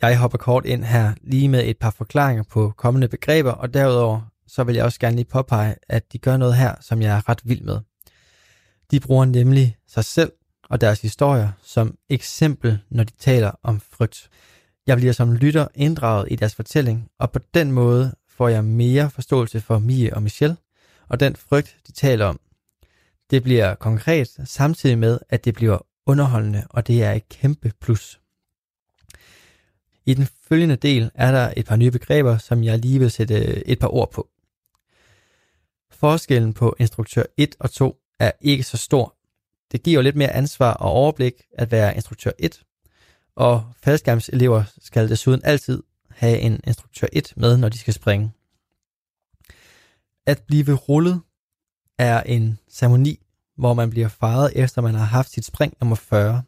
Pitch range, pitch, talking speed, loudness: 110-130 Hz, 120 Hz, 170 wpm, -19 LUFS